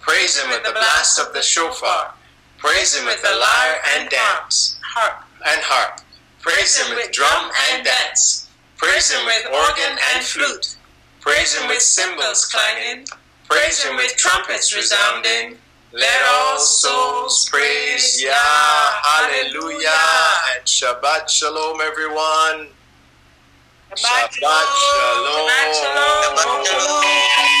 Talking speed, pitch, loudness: 125 wpm, 160 Hz, -15 LUFS